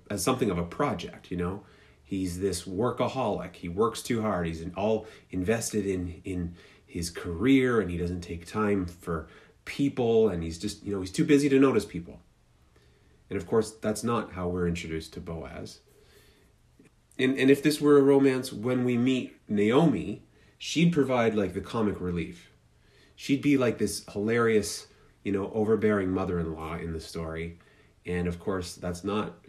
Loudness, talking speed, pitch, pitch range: -28 LUFS, 170 wpm, 100 Hz, 90-115 Hz